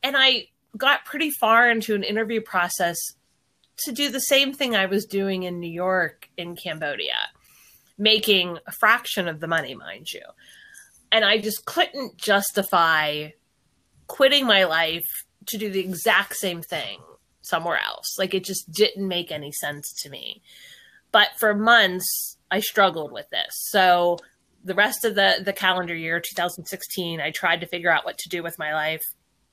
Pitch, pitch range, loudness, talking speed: 190 Hz, 170-220 Hz, -22 LUFS, 165 wpm